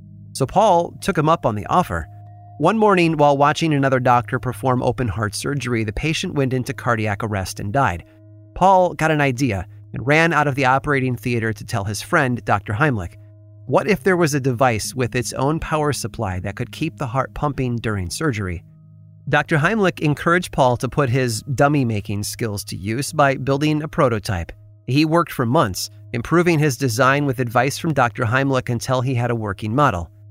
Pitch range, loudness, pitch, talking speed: 110-150 Hz, -19 LUFS, 130 Hz, 190 wpm